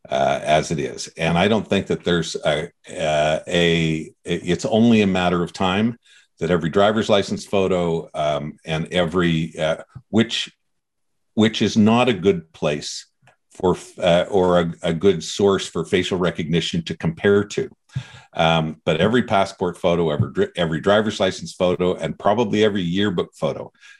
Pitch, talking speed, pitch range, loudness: 90 Hz, 160 wpm, 85-105 Hz, -20 LUFS